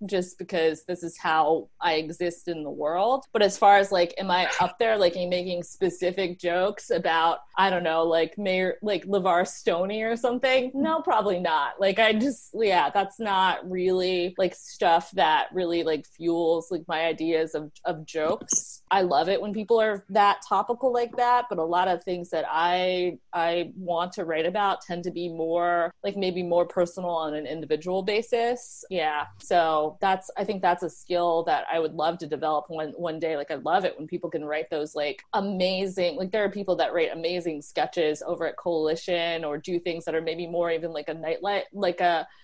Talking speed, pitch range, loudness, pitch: 200 wpm, 165-195 Hz, -26 LUFS, 175 Hz